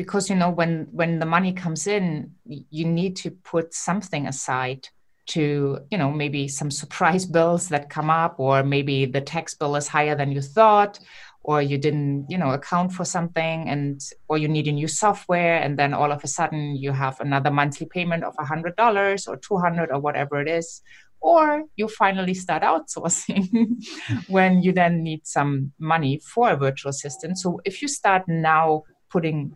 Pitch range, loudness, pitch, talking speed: 145-180 Hz, -22 LUFS, 160 Hz, 185 wpm